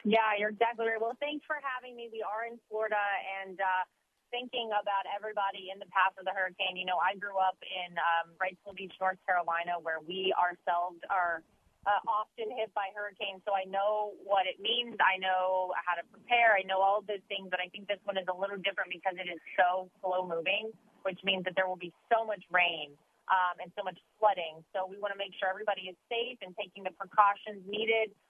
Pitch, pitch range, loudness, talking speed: 195 Hz, 185-210 Hz, -32 LUFS, 220 wpm